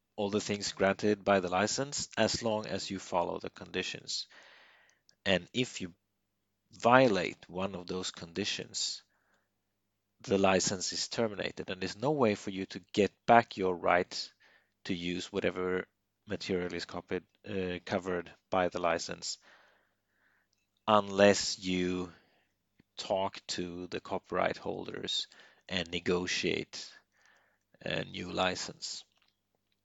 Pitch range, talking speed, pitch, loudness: 90-100 Hz, 120 wpm, 95 Hz, -32 LUFS